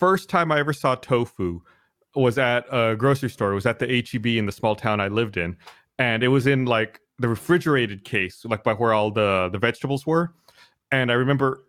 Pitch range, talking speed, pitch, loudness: 110-140 Hz, 215 wpm, 120 Hz, -22 LUFS